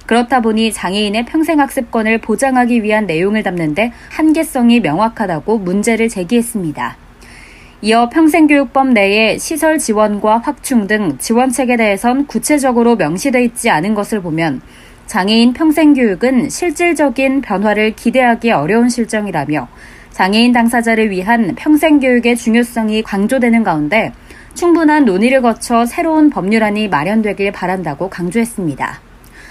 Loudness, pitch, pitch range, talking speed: -13 LUFS, 230 Hz, 210-260 Hz, 340 characters per minute